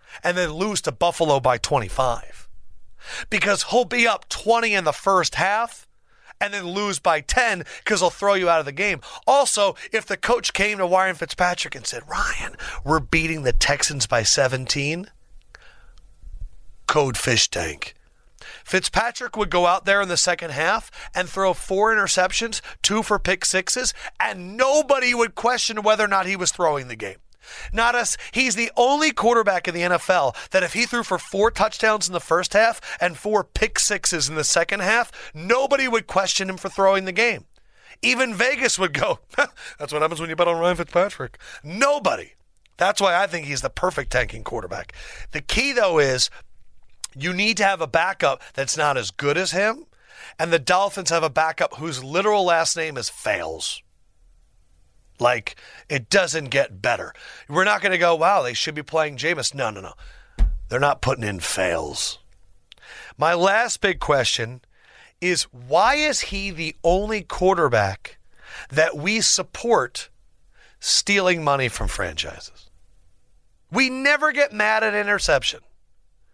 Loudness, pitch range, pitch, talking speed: -21 LUFS, 160-215 Hz, 185 Hz, 170 wpm